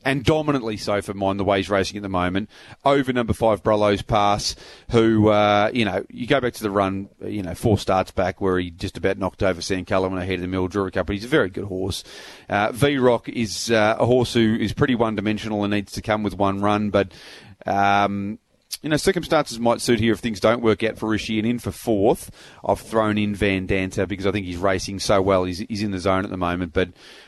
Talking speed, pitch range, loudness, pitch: 245 wpm, 95-115 Hz, -22 LUFS, 105 Hz